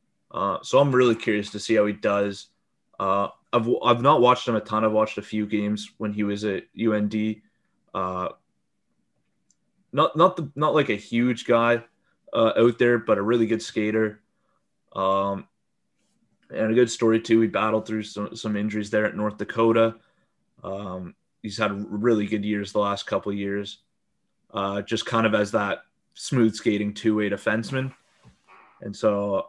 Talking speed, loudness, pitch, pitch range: 175 wpm, -24 LUFS, 110 Hz, 105-115 Hz